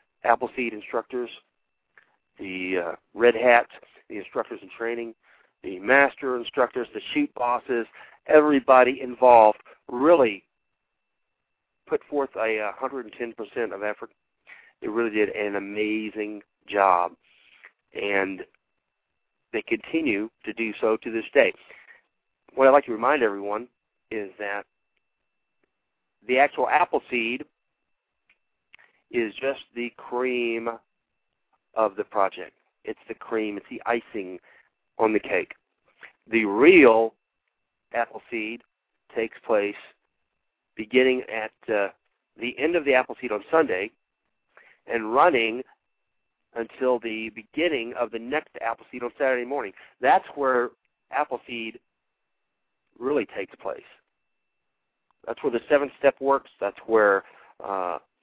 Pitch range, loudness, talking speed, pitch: 110-130 Hz, -24 LUFS, 115 wpm, 115 Hz